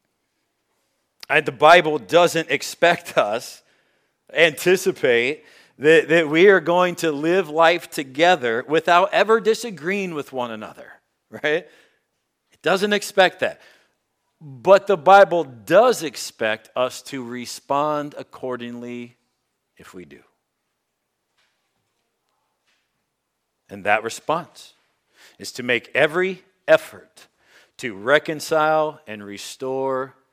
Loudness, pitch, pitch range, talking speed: -19 LUFS, 160 Hz, 130-185 Hz, 100 wpm